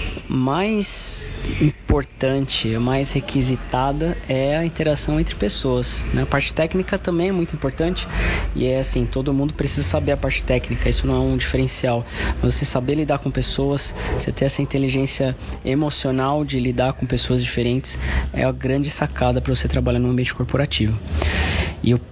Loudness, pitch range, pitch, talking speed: -20 LUFS, 125-140 Hz, 130 Hz, 165 wpm